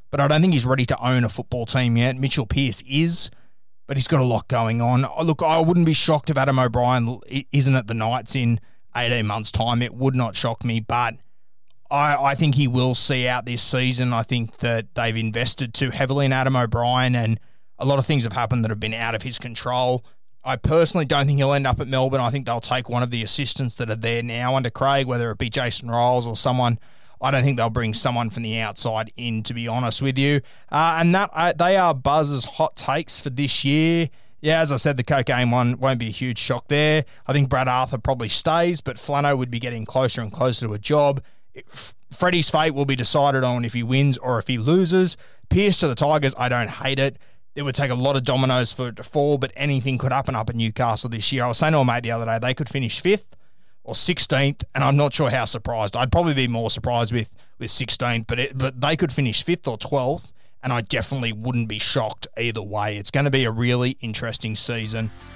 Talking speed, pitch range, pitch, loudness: 240 wpm, 115-140 Hz, 125 Hz, -21 LUFS